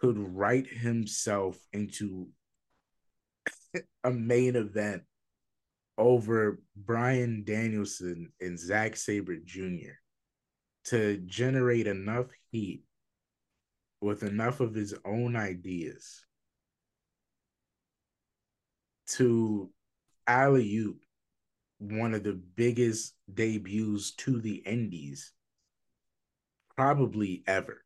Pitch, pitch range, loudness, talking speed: 105 Hz, 100-120 Hz, -31 LUFS, 80 wpm